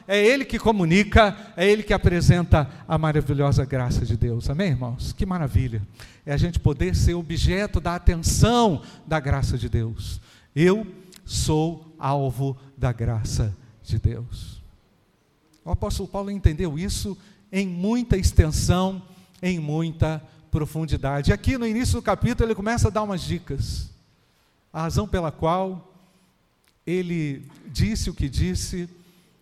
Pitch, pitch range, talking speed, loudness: 155 Hz, 120-185 Hz, 140 wpm, -23 LUFS